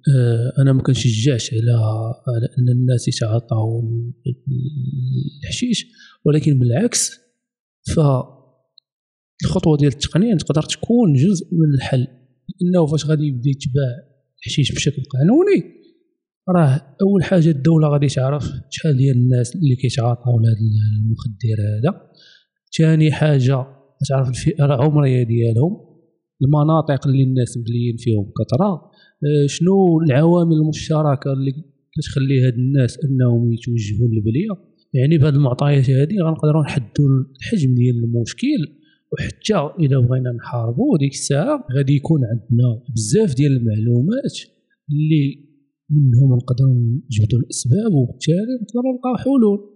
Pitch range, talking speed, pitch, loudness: 125-160 Hz, 110 wpm, 140 Hz, -18 LUFS